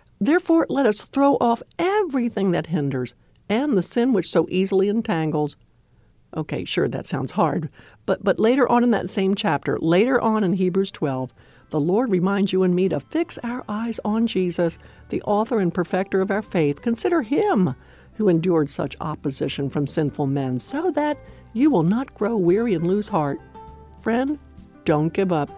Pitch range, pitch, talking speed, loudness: 160-235 Hz, 195 Hz, 175 wpm, -22 LUFS